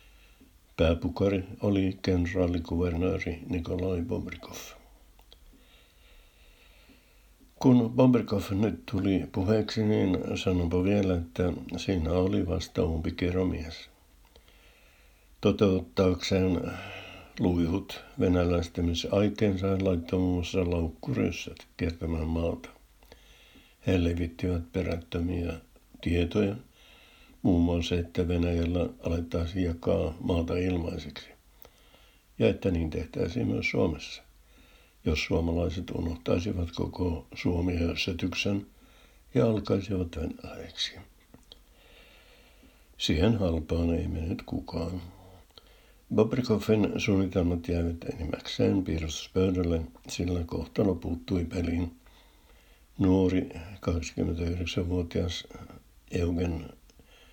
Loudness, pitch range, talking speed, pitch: -29 LUFS, 85-95 Hz, 75 wpm, 90 Hz